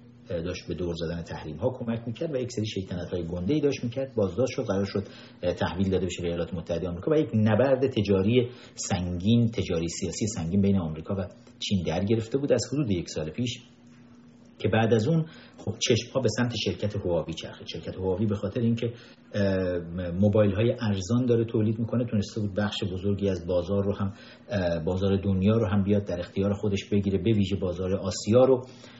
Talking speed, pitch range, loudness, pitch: 190 wpm, 95-120 Hz, -27 LUFS, 105 Hz